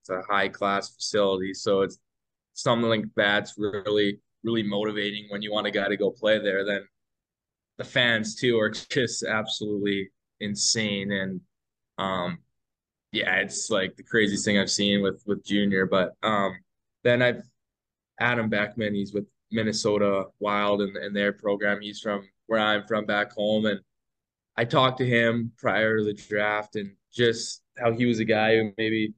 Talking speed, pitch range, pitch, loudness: 165 wpm, 100-110 Hz, 105 Hz, -25 LUFS